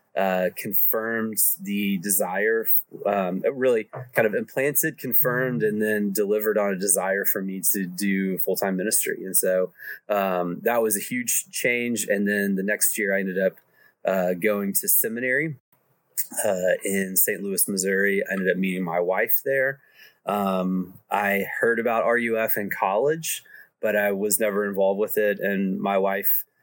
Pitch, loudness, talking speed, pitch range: 105 Hz, -23 LUFS, 160 wpm, 95-115 Hz